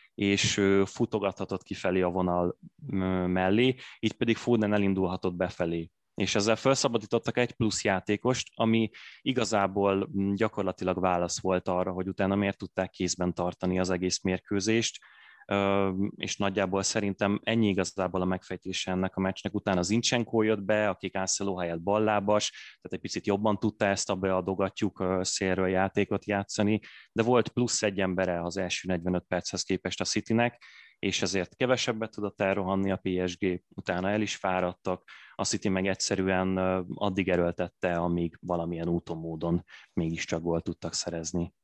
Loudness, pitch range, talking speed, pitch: -29 LUFS, 90-105 Hz, 140 wpm, 95 Hz